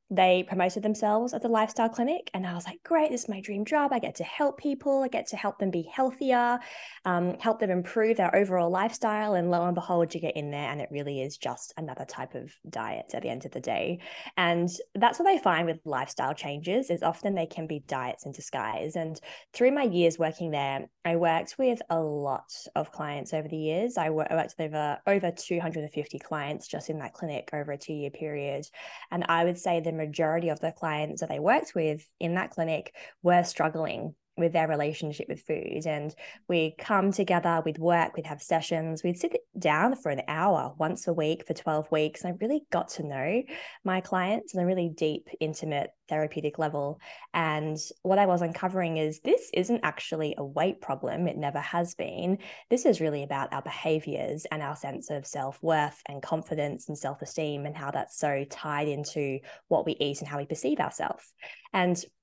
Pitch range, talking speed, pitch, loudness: 155-195 Hz, 205 wpm, 165 Hz, -29 LUFS